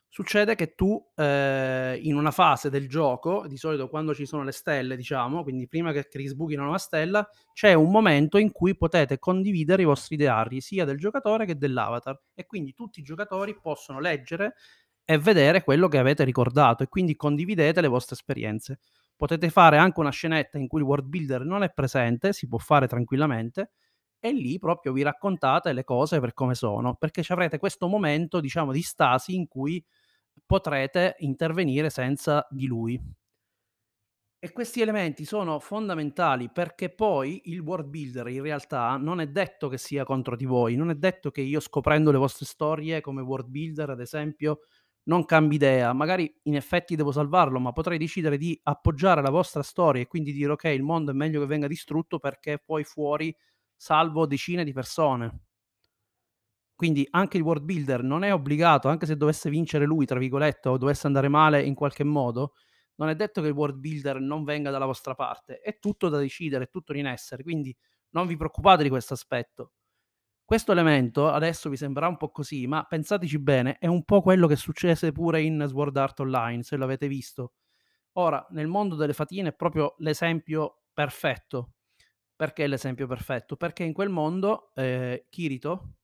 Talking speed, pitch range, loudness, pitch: 180 wpm, 135-170 Hz, -25 LUFS, 150 Hz